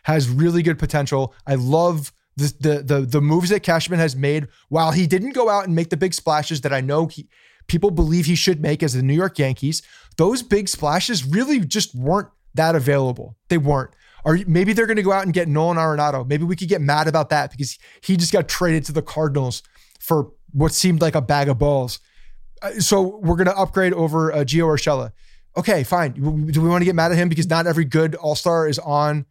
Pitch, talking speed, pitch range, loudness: 160 Hz, 225 wpm, 145-175 Hz, -19 LUFS